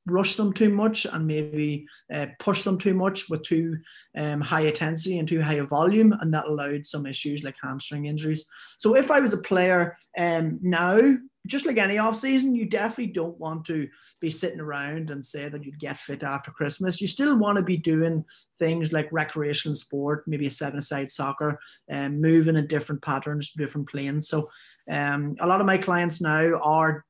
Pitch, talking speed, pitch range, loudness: 155 Hz, 200 wpm, 145-185 Hz, -25 LUFS